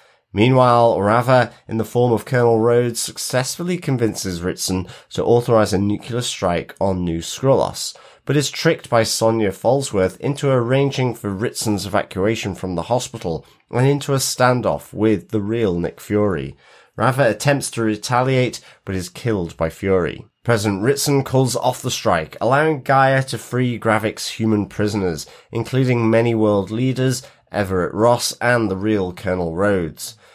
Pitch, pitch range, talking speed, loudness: 115 Hz, 100-125 Hz, 150 wpm, -19 LUFS